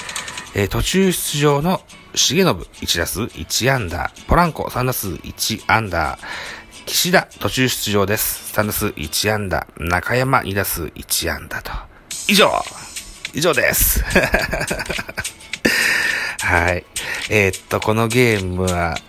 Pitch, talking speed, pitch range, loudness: 105 Hz, 205 characters per minute, 95-125 Hz, -18 LUFS